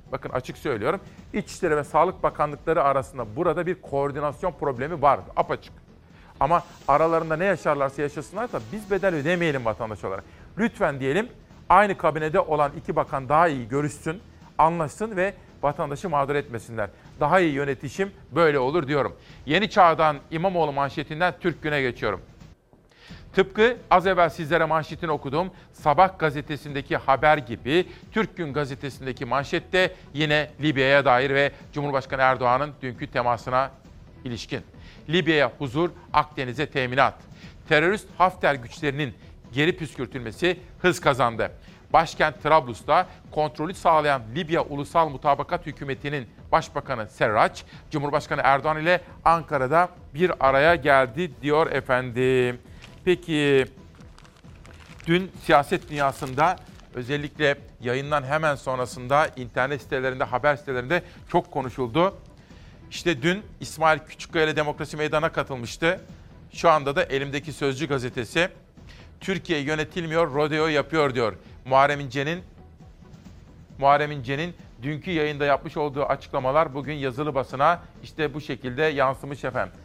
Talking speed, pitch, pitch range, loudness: 115 wpm, 150 Hz, 135-165 Hz, -24 LUFS